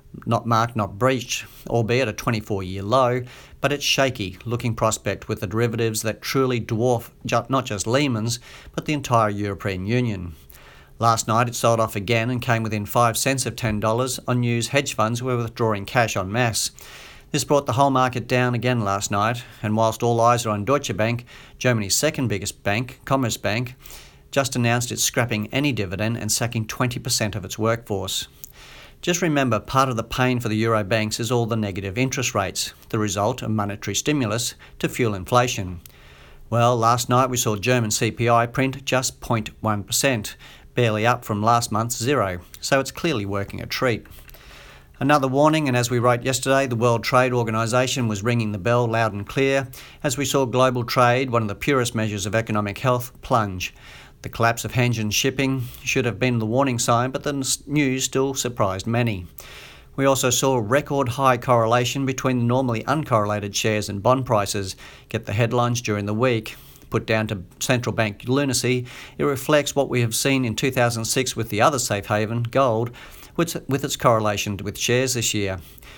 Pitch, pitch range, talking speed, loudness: 120 Hz, 110-130 Hz, 175 wpm, -22 LUFS